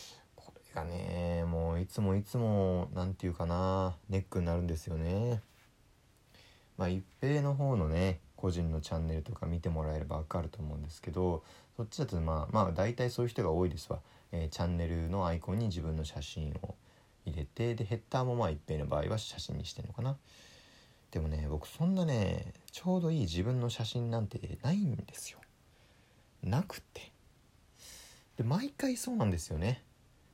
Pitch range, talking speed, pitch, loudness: 85-120 Hz, 340 characters per minute, 95 Hz, -35 LUFS